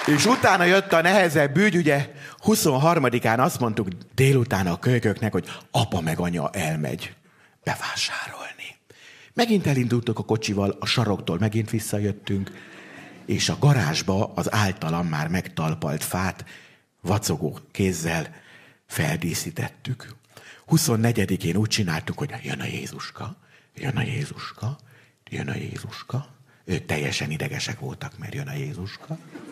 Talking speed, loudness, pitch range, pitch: 120 wpm, -24 LUFS, 100-145 Hz, 125 Hz